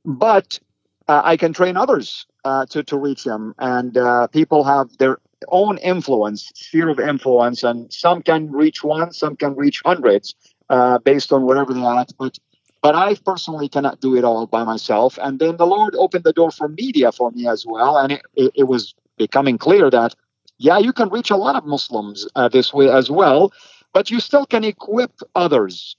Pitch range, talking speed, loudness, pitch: 130-170 Hz, 195 wpm, -17 LUFS, 145 Hz